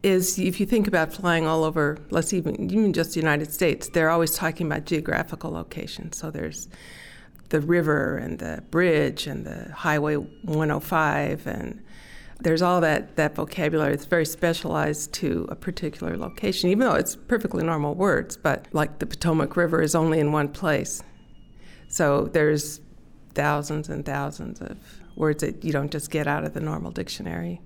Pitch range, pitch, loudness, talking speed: 150-170 Hz, 155 Hz, -25 LUFS, 170 wpm